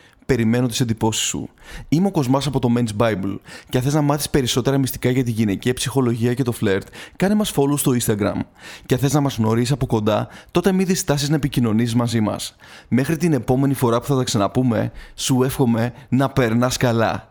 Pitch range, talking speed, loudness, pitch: 115-140 Hz, 200 wpm, -20 LUFS, 125 Hz